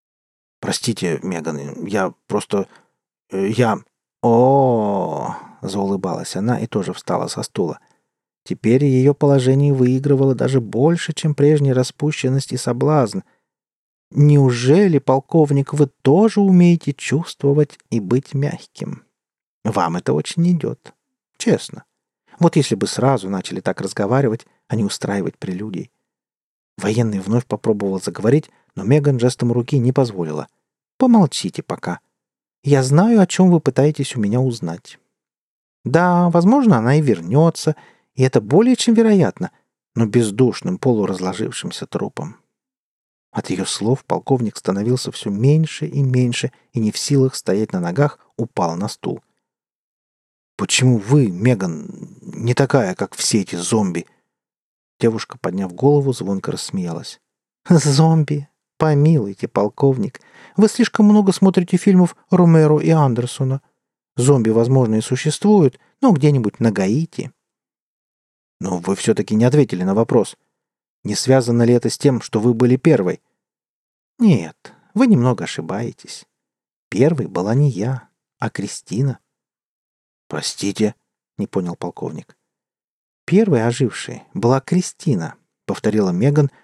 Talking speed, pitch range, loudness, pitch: 120 wpm, 115-155 Hz, -17 LUFS, 135 Hz